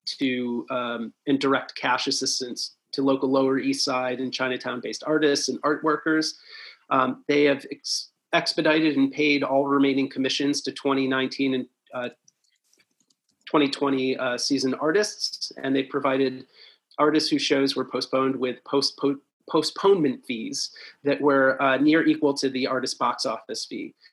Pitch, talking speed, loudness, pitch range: 135 Hz, 145 wpm, -24 LUFS, 130-150 Hz